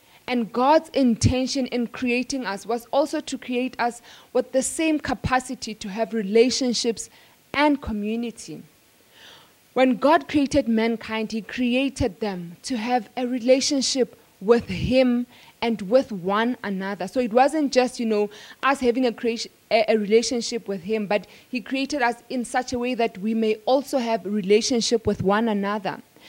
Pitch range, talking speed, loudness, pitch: 220-255 Hz, 160 wpm, -23 LUFS, 240 Hz